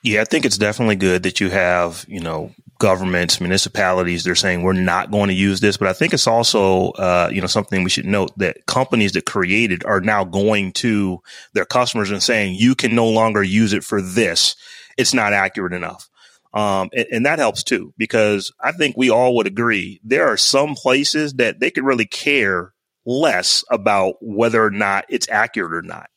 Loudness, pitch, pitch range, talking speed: -17 LUFS, 105 Hz, 95-115 Hz, 200 wpm